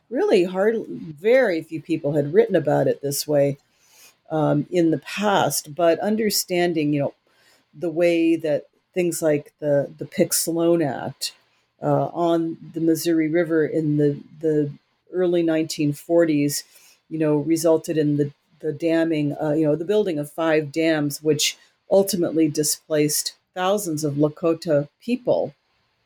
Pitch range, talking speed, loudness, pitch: 150-170 Hz, 140 wpm, -22 LUFS, 160 Hz